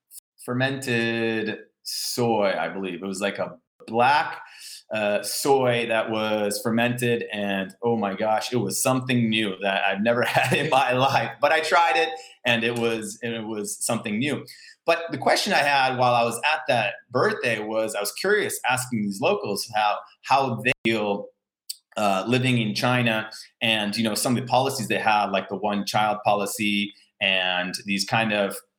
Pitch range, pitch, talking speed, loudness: 105-125 Hz, 110 Hz, 175 wpm, -23 LUFS